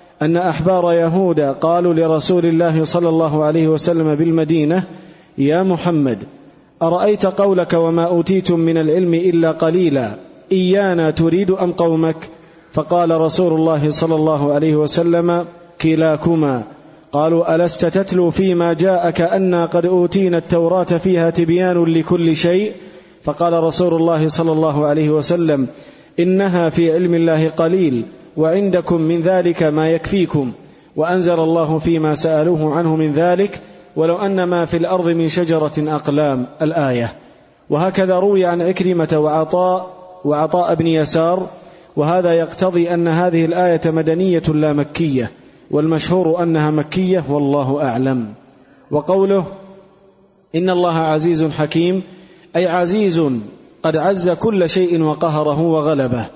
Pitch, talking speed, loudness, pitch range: 165 Hz, 120 wpm, -16 LUFS, 155-180 Hz